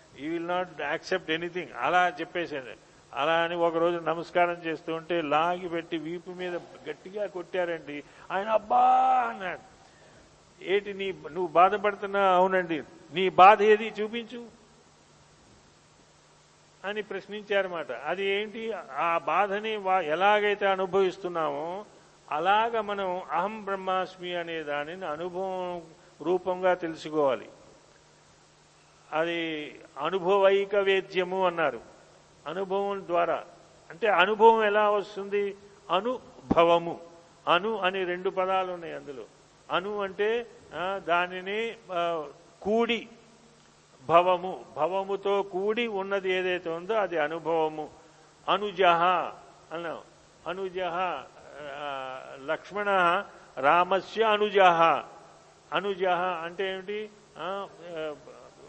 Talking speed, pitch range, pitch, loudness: 85 wpm, 165-200 Hz, 180 Hz, -27 LUFS